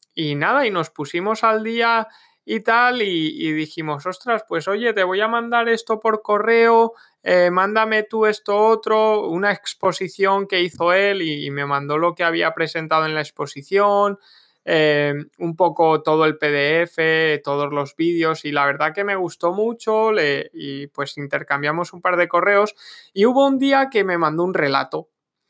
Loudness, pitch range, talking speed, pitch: -19 LUFS, 155-215 Hz, 180 wpm, 180 Hz